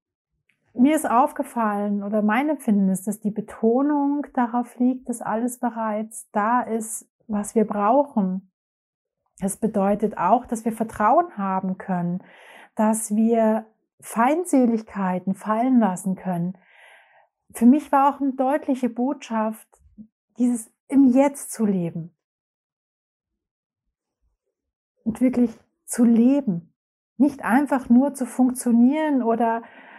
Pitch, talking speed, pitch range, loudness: 230 Hz, 110 wpm, 210-255 Hz, -22 LUFS